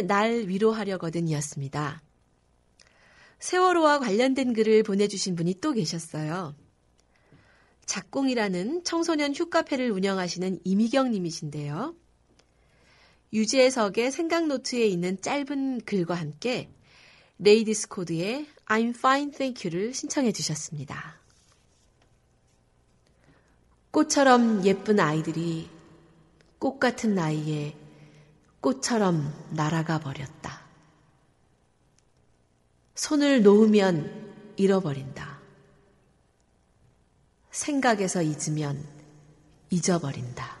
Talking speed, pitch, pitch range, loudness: 225 characters per minute, 185 Hz, 150-235 Hz, -26 LUFS